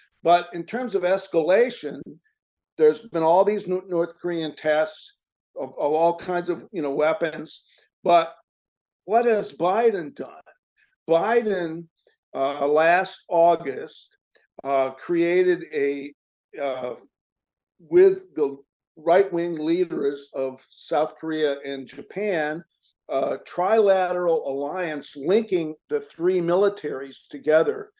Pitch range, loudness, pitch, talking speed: 155-195 Hz, -23 LUFS, 170 Hz, 110 wpm